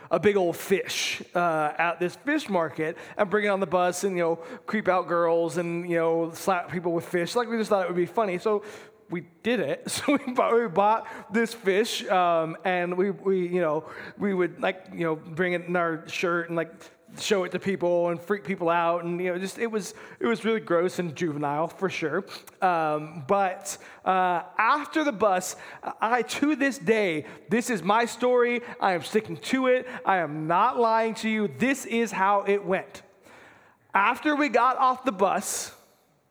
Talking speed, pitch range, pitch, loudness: 205 wpm, 170-225 Hz, 190 Hz, -26 LUFS